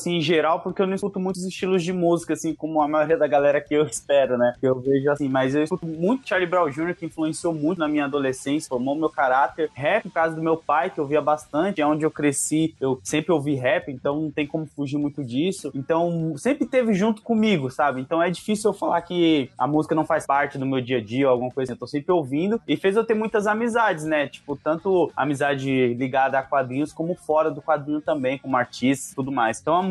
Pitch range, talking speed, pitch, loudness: 140-170 Hz, 240 wpm, 155 Hz, -23 LUFS